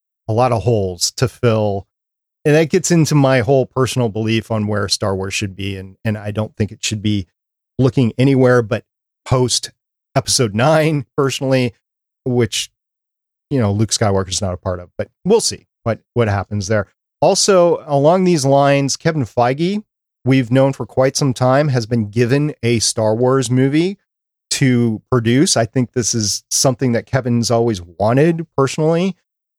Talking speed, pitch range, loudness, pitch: 170 wpm, 110-135 Hz, -16 LUFS, 125 Hz